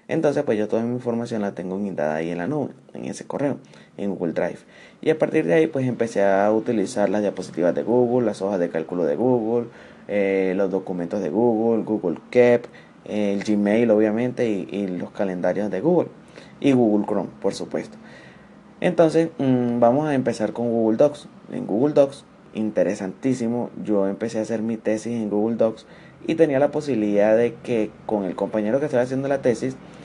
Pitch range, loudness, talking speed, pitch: 105-130 Hz, -22 LUFS, 190 wpm, 115 Hz